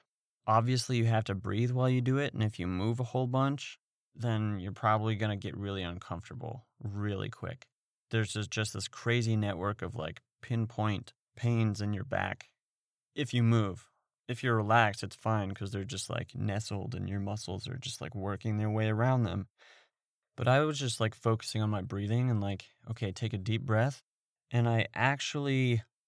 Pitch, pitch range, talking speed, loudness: 110 Hz, 105-125 Hz, 190 wpm, -32 LUFS